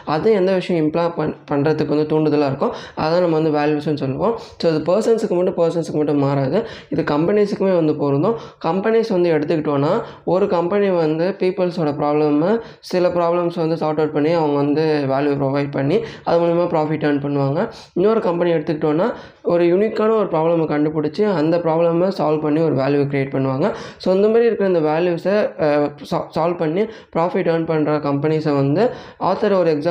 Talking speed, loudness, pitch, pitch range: 165 wpm, -18 LUFS, 160 Hz, 150-180 Hz